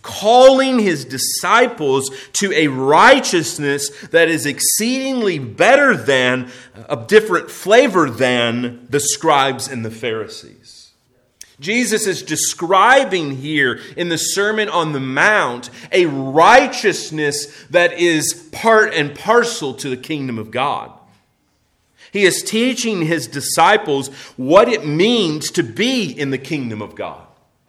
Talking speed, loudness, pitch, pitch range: 125 wpm, -15 LUFS, 155 Hz, 135-200 Hz